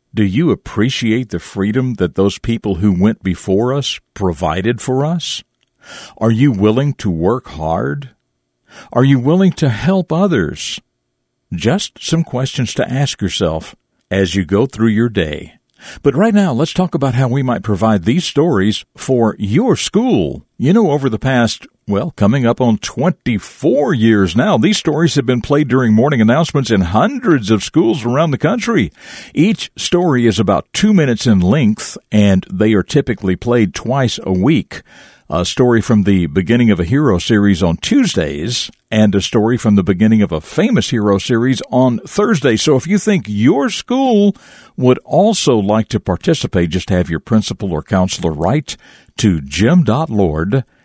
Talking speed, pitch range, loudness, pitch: 165 wpm, 100-140 Hz, -14 LUFS, 115 Hz